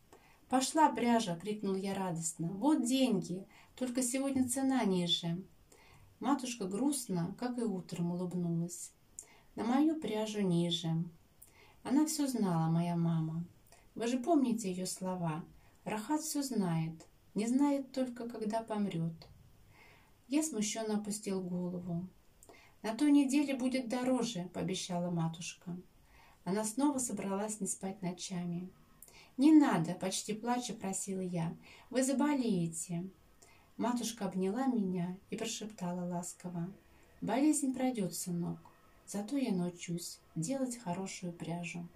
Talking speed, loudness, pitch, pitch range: 115 wpm, -35 LUFS, 195 Hz, 175-250 Hz